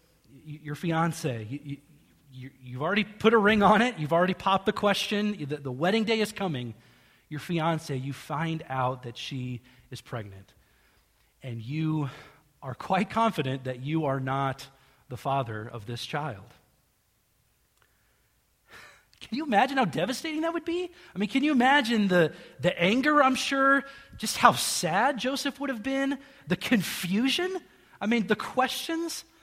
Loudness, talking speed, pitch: -27 LUFS, 155 wpm, 165 Hz